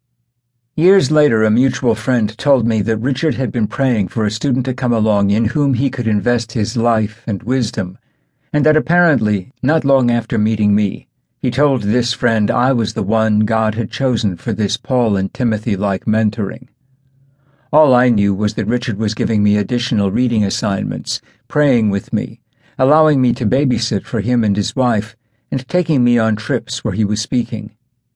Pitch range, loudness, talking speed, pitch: 110-130 Hz, -16 LUFS, 180 wpm, 120 Hz